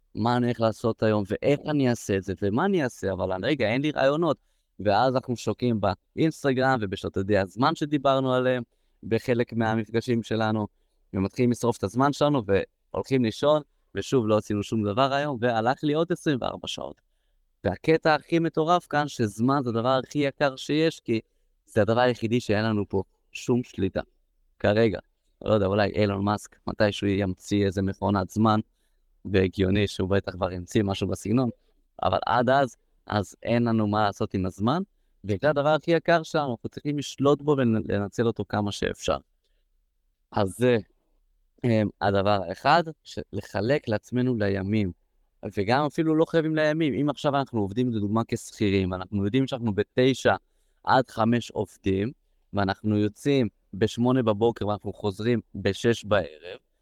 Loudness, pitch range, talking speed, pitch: -26 LUFS, 100-135 Hz, 150 wpm, 115 Hz